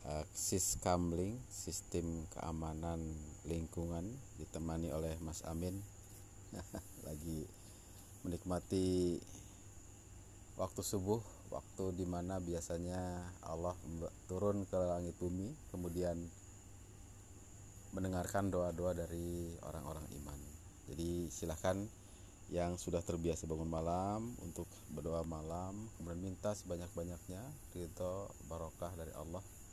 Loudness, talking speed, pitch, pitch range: -43 LUFS, 90 wpm, 90 Hz, 85-100 Hz